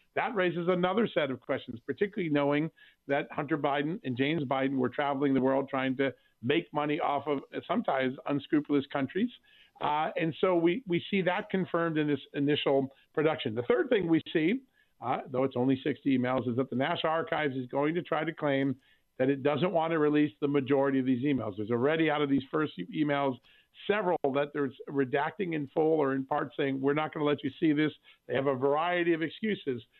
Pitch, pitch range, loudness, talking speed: 145 Hz, 135-160 Hz, -30 LUFS, 210 wpm